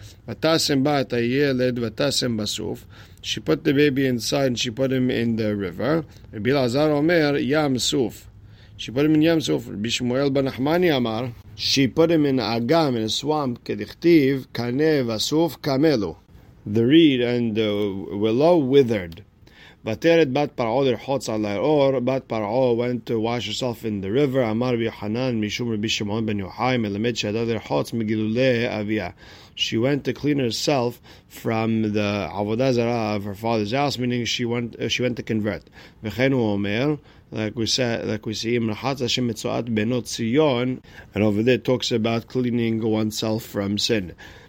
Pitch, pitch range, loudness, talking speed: 120 Hz, 110-135 Hz, -22 LUFS, 160 wpm